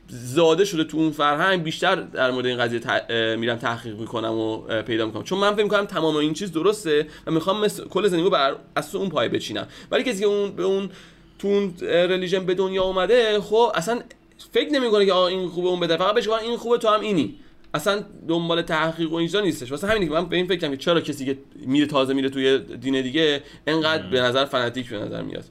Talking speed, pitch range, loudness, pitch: 215 wpm, 135-195 Hz, -22 LUFS, 165 Hz